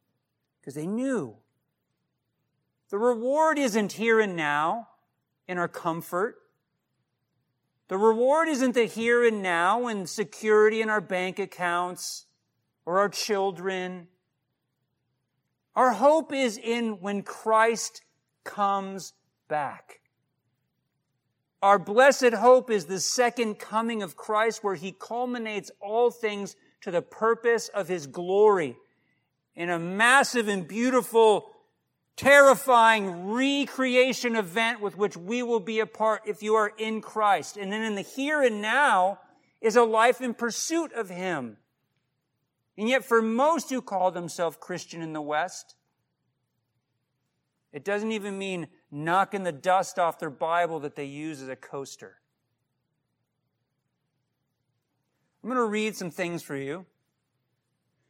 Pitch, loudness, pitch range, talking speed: 200 Hz, -25 LUFS, 160-230 Hz, 130 wpm